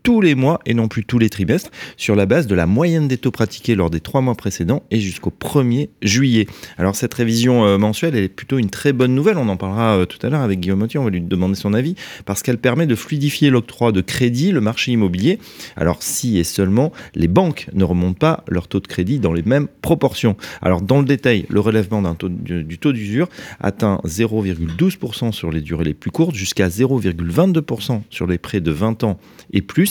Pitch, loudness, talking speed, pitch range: 110 Hz, -18 LUFS, 225 wpm, 95-135 Hz